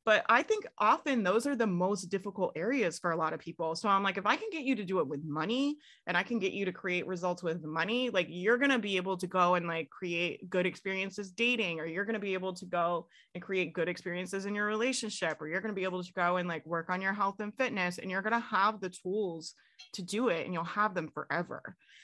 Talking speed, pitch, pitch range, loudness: 265 wpm, 185 Hz, 175-210 Hz, -32 LUFS